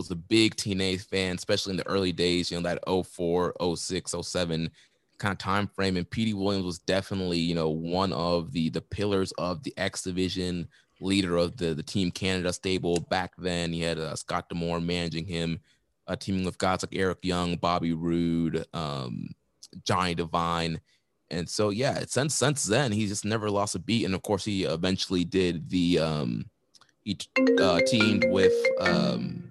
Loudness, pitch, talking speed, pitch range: -28 LUFS, 90 Hz, 180 wpm, 85-95 Hz